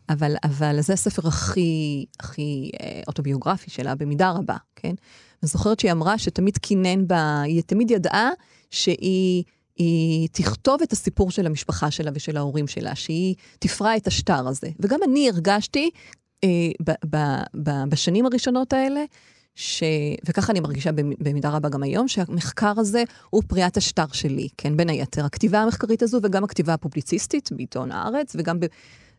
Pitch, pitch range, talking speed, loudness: 175 Hz, 150-210 Hz, 150 wpm, -23 LUFS